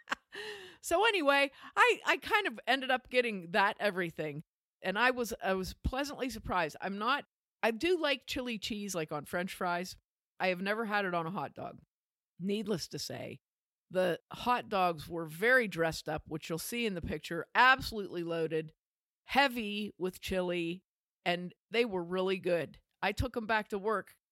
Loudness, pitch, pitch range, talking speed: -33 LUFS, 200 Hz, 175-245 Hz, 175 wpm